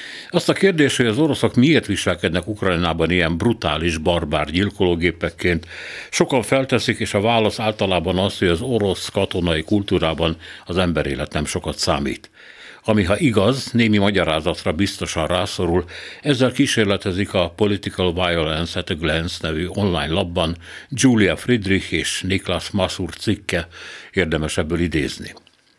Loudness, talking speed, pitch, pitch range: -20 LUFS, 135 wpm, 95 Hz, 85-110 Hz